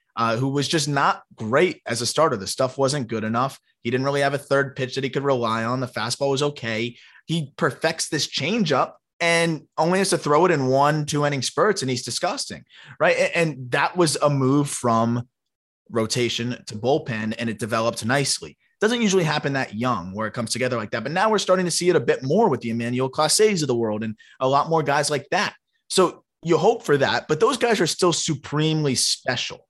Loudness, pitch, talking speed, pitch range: -22 LUFS, 135 Hz, 220 wpm, 120-155 Hz